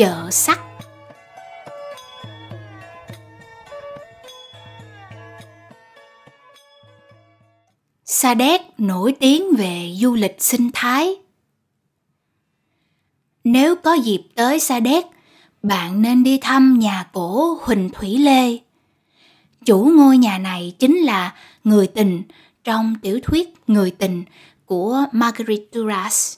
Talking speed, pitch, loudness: 95 wpm, 200 Hz, -17 LUFS